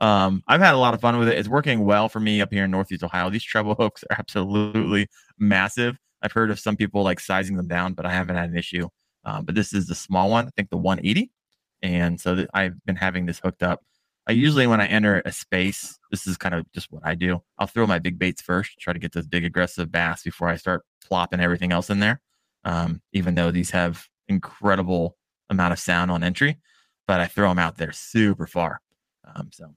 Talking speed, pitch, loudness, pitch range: 235 wpm, 95 Hz, -23 LUFS, 85-105 Hz